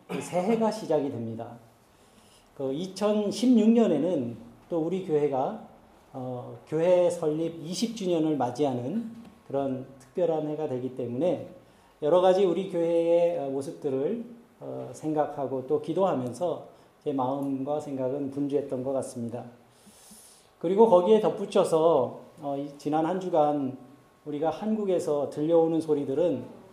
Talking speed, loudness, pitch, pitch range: 260 characters per minute, -27 LUFS, 155 Hz, 135-180 Hz